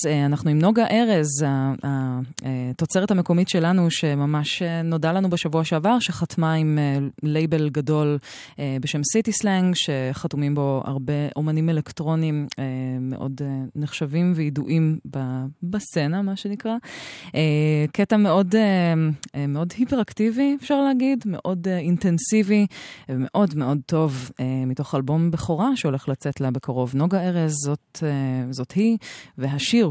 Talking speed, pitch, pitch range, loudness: 110 wpm, 155 Hz, 140-185 Hz, -22 LUFS